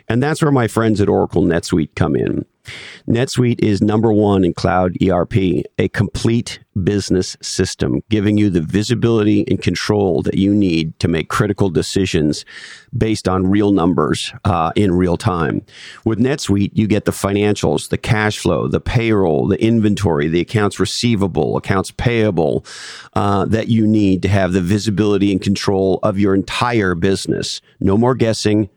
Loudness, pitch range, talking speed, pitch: -16 LUFS, 95-110 Hz, 160 wpm, 100 Hz